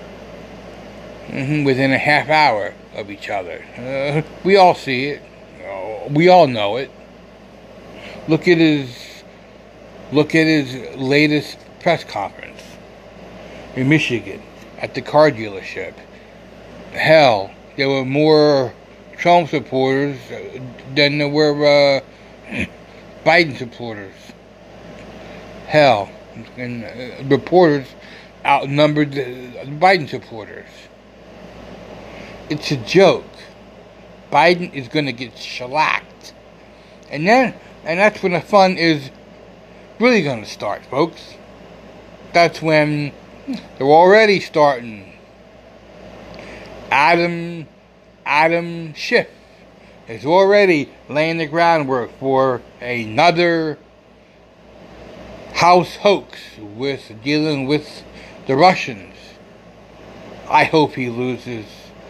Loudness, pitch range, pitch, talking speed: -16 LUFS, 135-190 Hz, 150 Hz, 100 wpm